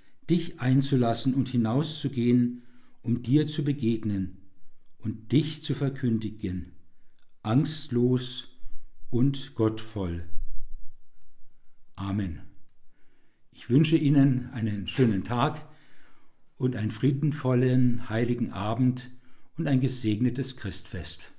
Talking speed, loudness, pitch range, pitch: 85 wpm, -27 LUFS, 105-135 Hz, 120 Hz